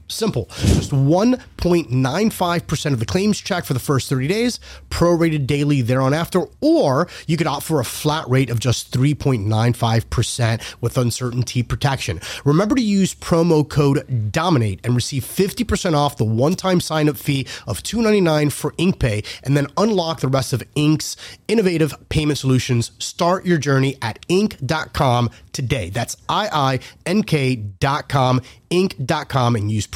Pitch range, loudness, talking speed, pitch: 125-170 Hz, -19 LUFS, 150 wpm, 140 Hz